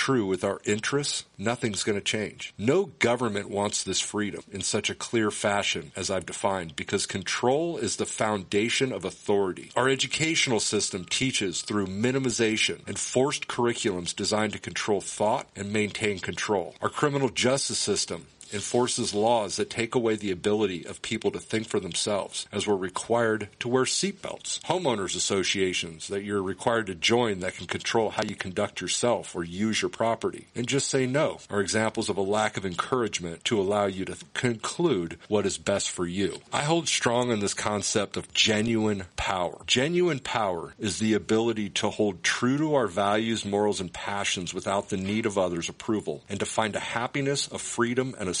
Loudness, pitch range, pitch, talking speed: -27 LUFS, 100-125 Hz, 110 Hz, 180 wpm